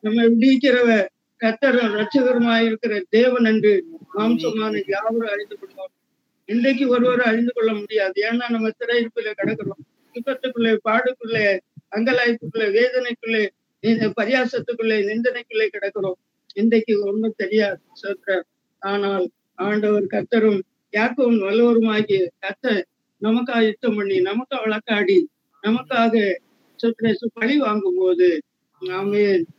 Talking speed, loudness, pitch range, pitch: 100 wpm, -20 LUFS, 205-245 Hz, 225 Hz